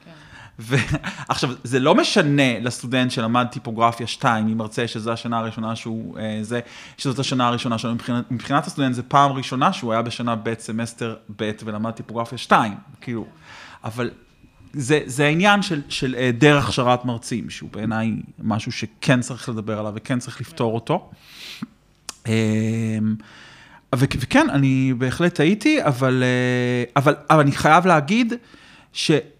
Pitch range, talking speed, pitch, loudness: 115-140 Hz, 135 wpm, 125 Hz, -21 LUFS